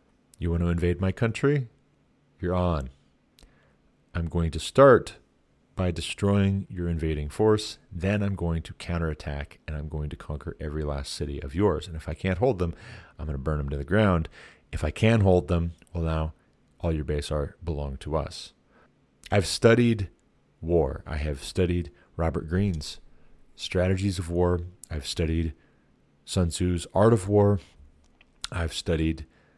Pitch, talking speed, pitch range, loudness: 85 Hz, 160 wpm, 75-95 Hz, -27 LUFS